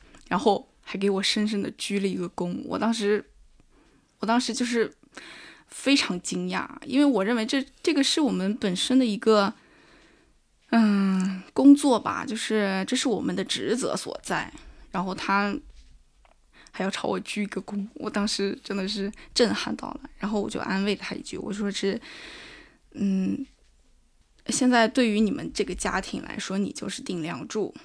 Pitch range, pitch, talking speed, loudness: 195-255 Hz, 215 Hz, 235 characters per minute, -26 LUFS